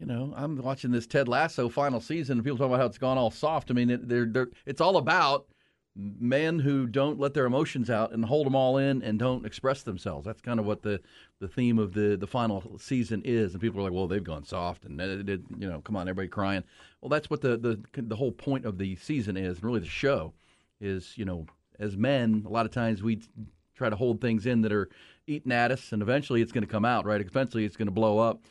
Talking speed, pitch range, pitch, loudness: 250 wpm, 105-130 Hz, 115 Hz, -29 LUFS